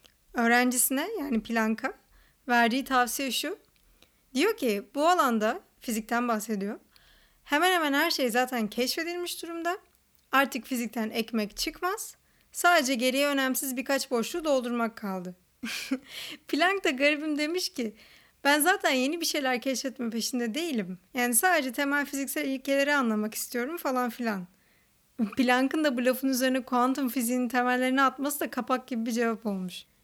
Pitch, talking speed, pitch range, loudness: 260 Hz, 135 wpm, 235-295 Hz, -27 LUFS